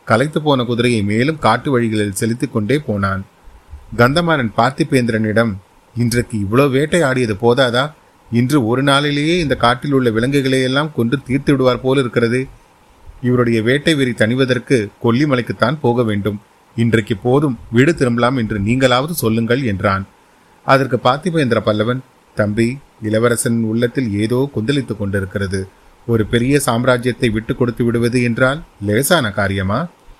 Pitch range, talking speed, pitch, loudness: 110-135 Hz, 120 wpm, 120 Hz, -16 LUFS